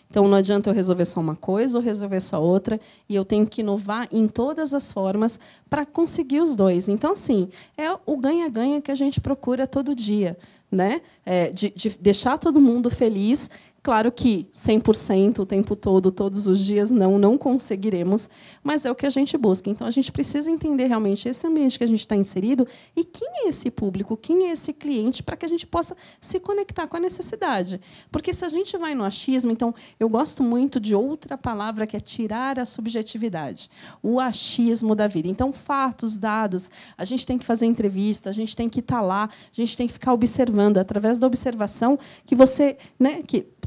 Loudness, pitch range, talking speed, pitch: -23 LUFS, 205-275 Hz, 200 wpm, 230 Hz